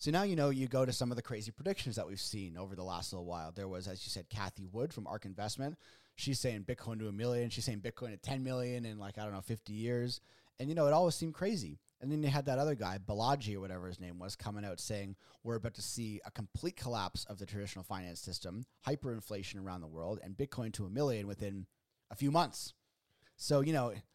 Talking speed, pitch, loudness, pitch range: 250 wpm, 110 Hz, -39 LUFS, 95-130 Hz